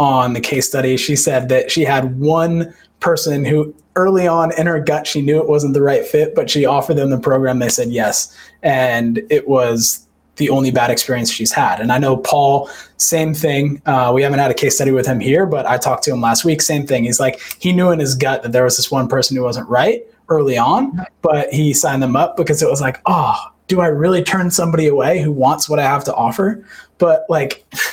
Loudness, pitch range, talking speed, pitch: -15 LUFS, 130-165 Hz, 235 wpm, 145 Hz